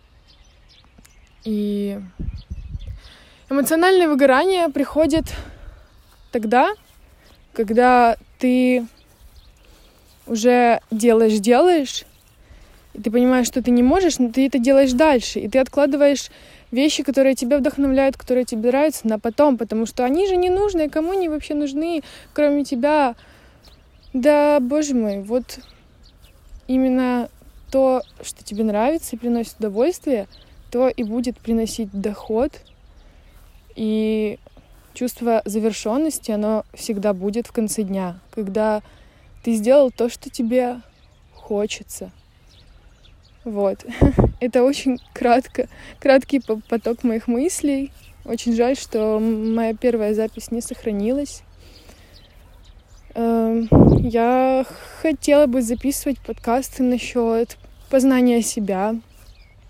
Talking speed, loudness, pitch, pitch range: 105 wpm, -19 LUFS, 245 Hz, 220-275 Hz